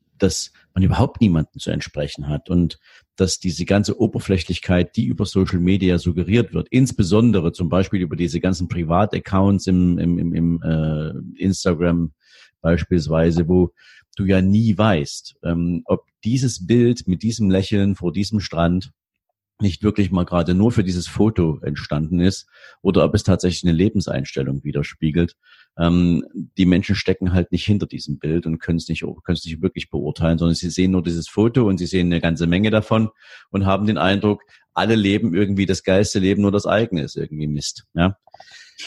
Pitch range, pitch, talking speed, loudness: 85-100 Hz, 90 Hz, 175 wpm, -20 LUFS